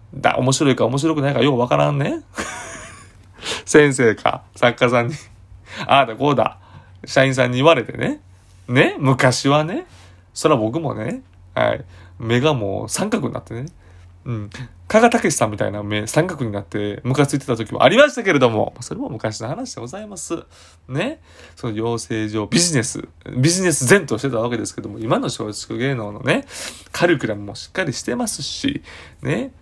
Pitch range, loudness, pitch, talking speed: 100-140 Hz, -19 LUFS, 120 Hz, 330 characters per minute